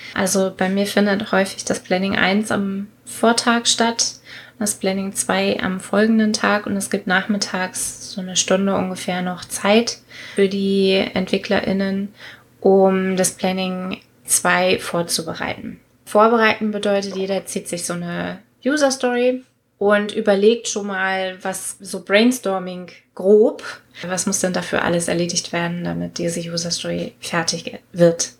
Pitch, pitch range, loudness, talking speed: 195 Hz, 185-210 Hz, -19 LUFS, 135 wpm